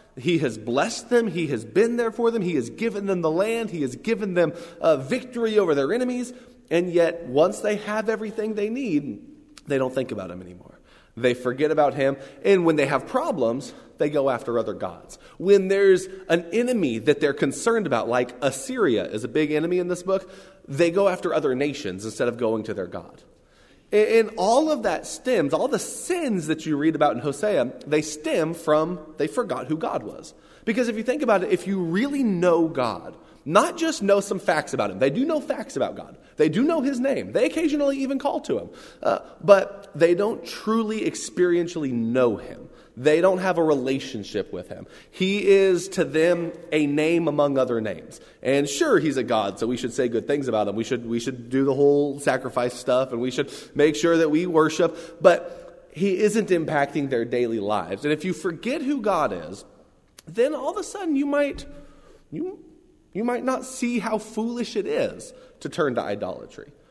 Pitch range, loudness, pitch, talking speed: 145-230 Hz, -23 LUFS, 180 Hz, 205 wpm